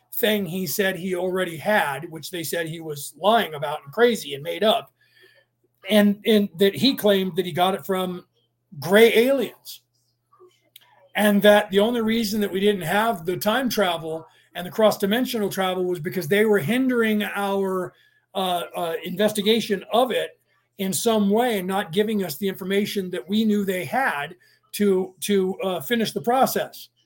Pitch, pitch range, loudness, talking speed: 200 Hz, 180-215 Hz, -22 LUFS, 170 wpm